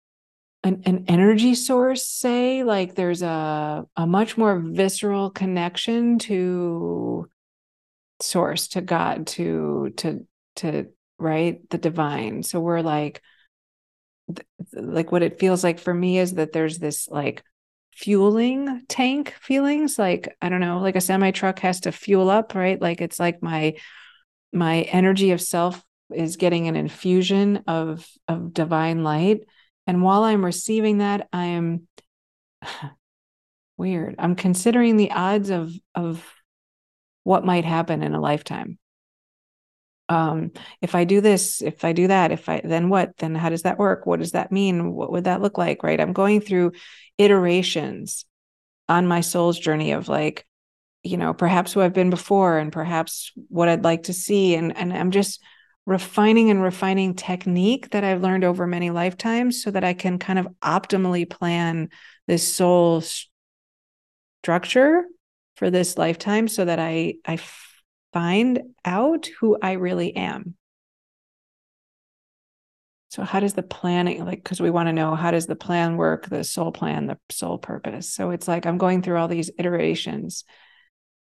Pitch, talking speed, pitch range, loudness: 180 Hz, 155 wpm, 170-195 Hz, -22 LUFS